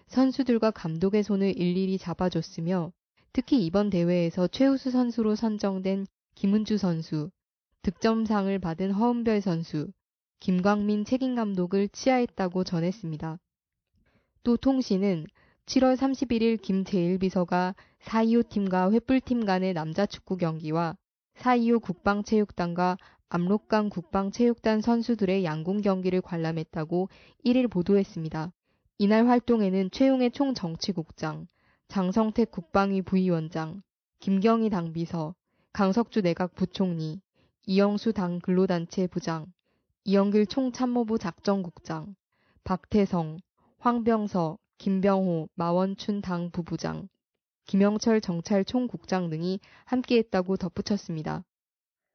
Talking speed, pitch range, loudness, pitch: 260 characters per minute, 175-220 Hz, -27 LUFS, 195 Hz